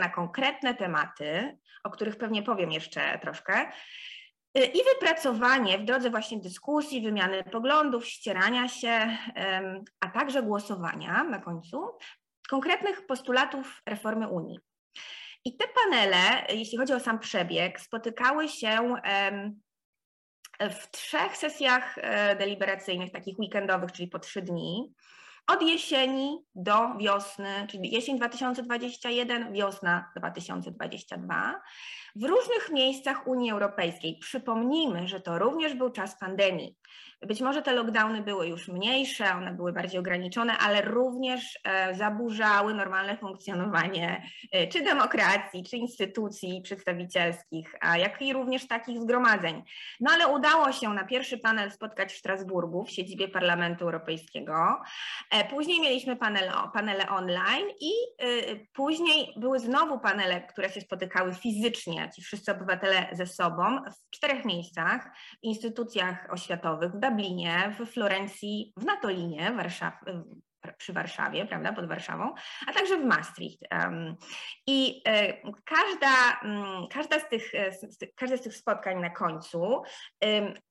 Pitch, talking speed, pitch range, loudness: 215 Hz, 125 wpm, 190-260 Hz, -28 LUFS